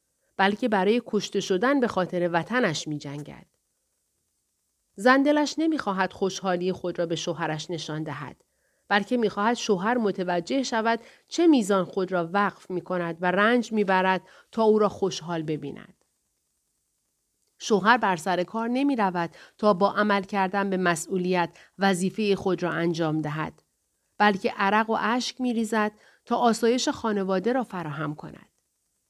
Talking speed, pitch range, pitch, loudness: 140 wpm, 175-225 Hz, 195 Hz, -25 LUFS